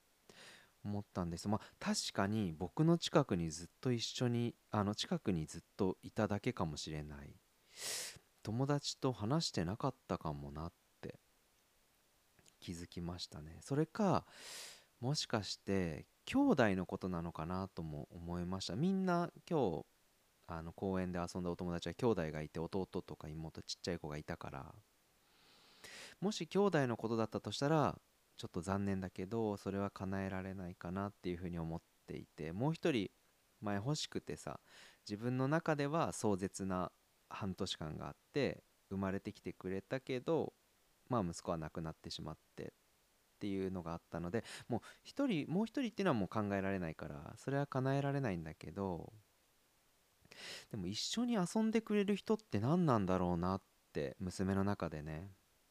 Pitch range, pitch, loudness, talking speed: 85-130 Hz, 95 Hz, -40 LUFS, 325 characters per minute